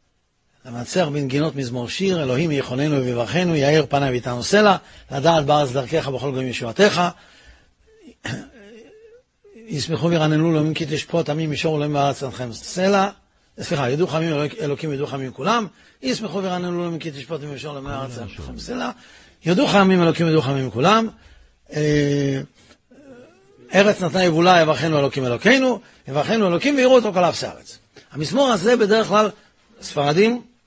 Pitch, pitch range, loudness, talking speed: 155 Hz, 140-195 Hz, -20 LUFS, 135 wpm